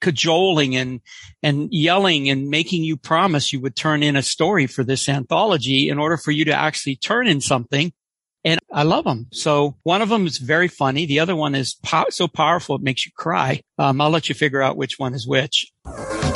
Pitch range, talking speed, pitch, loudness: 135-165 Hz, 215 wpm, 150 Hz, -19 LUFS